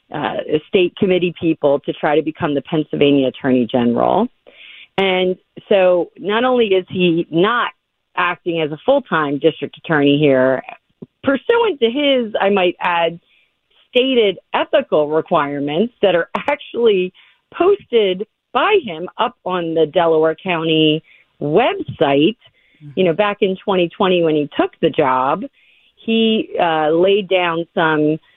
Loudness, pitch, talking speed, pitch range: -16 LUFS, 180 Hz, 135 wpm, 155-215 Hz